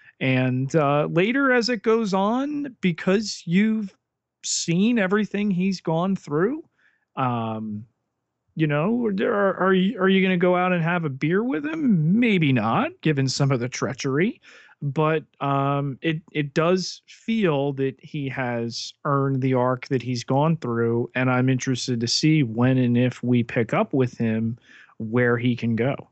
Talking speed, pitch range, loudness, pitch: 170 wpm, 125-190 Hz, -23 LUFS, 150 Hz